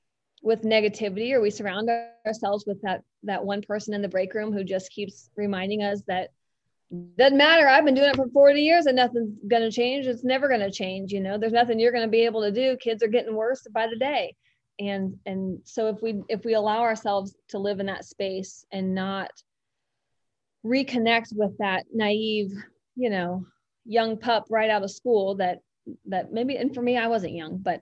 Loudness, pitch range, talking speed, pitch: -24 LUFS, 195-235 Hz, 205 wpm, 215 Hz